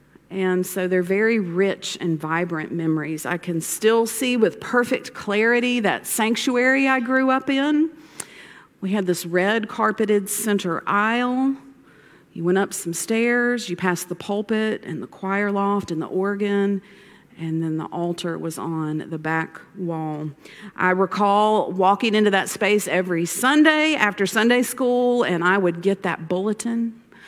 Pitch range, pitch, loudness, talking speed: 175-230 Hz, 200 Hz, -21 LUFS, 155 wpm